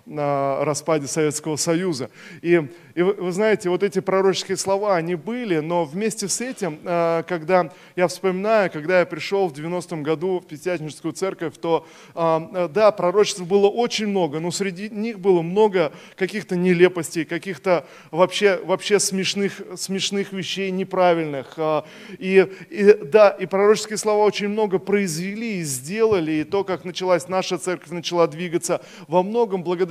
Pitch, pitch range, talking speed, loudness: 185 Hz, 170-200 Hz, 145 wpm, -21 LUFS